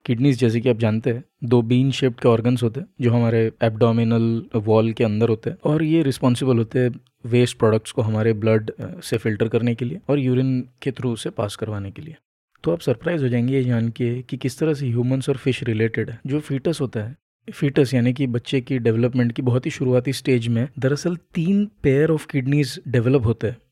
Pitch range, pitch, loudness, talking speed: 115-140 Hz, 125 Hz, -21 LUFS, 220 wpm